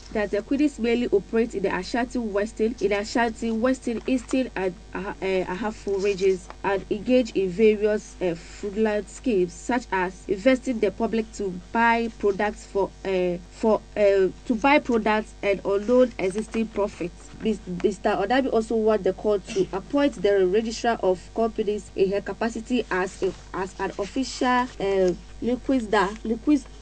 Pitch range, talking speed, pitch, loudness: 195-235 Hz, 140 wpm, 210 Hz, -24 LUFS